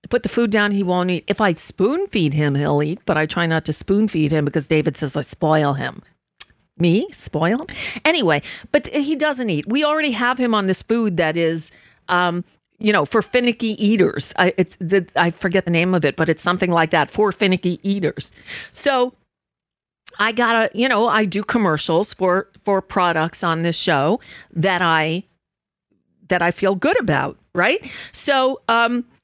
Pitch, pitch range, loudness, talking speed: 190 Hz, 165-225 Hz, -19 LUFS, 190 wpm